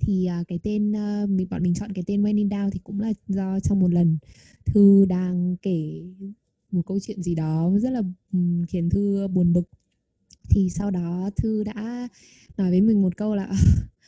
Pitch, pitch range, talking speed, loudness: 190 Hz, 175-205 Hz, 185 wpm, -23 LUFS